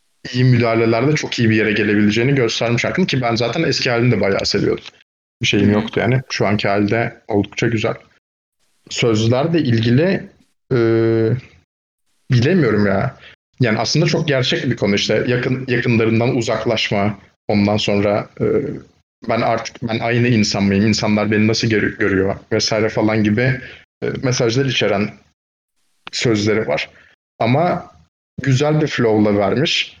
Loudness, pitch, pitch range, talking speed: -17 LUFS, 115 Hz, 105-125 Hz, 135 wpm